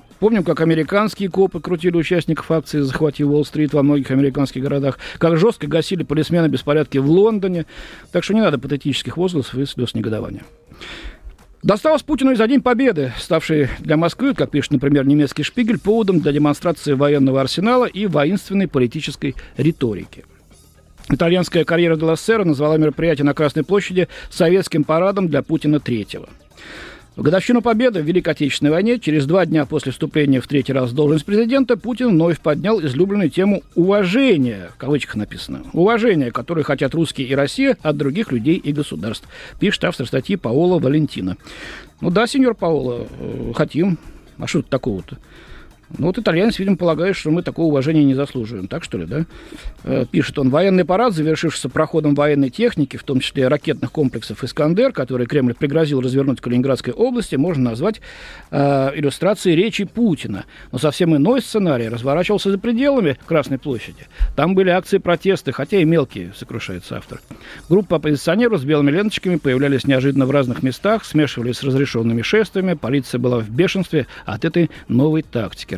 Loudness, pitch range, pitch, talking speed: -18 LUFS, 135-180 Hz, 155 Hz, 160 wpm